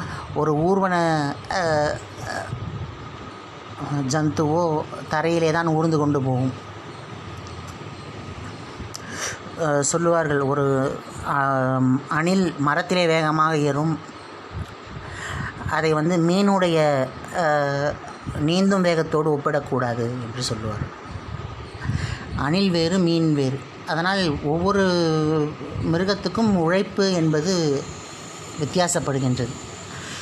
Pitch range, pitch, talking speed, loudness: 135-165 Hz, 150 Hz, 65 wpm, -22 LUFS